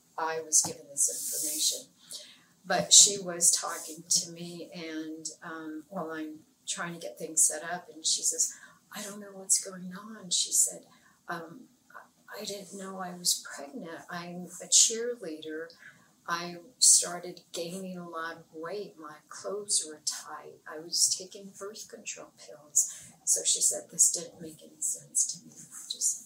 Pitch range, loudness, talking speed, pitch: 160-195 Hz, -26 LUFS, 160 wpm, 175 Hz